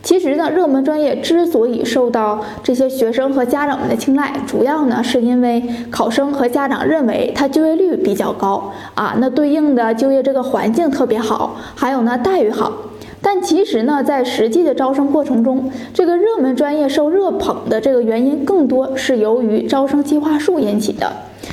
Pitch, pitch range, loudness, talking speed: 270 Hz, 240-300 Hz, -15 LUFS, 285 characters per minute